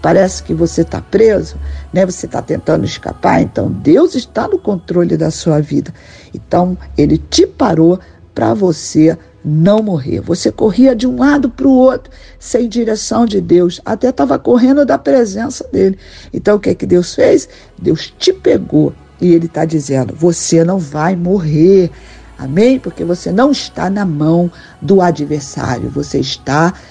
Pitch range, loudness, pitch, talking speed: 160-235 Hz, -12 LUFS, 180 Hz, 165 wpm